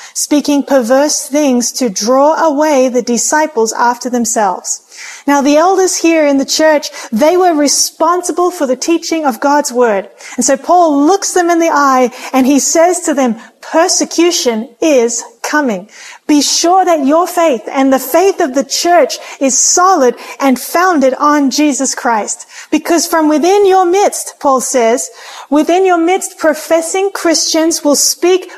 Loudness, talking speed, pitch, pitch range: -11 LUFS, 155 wpm, 300 Hz, 265-340 Hz